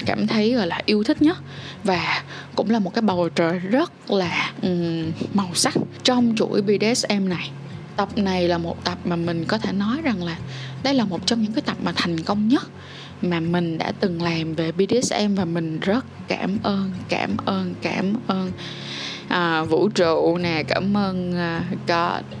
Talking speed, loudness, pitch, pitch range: 185 wpm, -22 LUFS, 185 Hz, 170-215 Hz